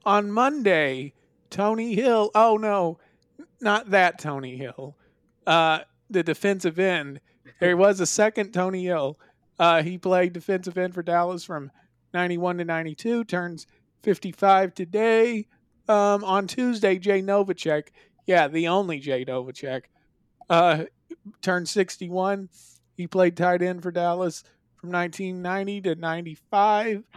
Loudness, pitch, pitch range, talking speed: -23 LUFS, 180 Hz, 165-200 Hz, 125 wpm